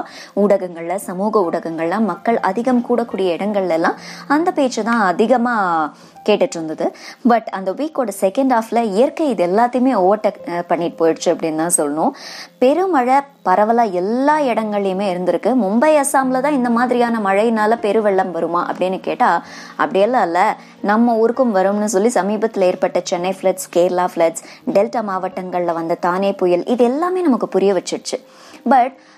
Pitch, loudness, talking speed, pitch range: 210 Hz, -17 LUFS, 135 wpm, 180-250 Hz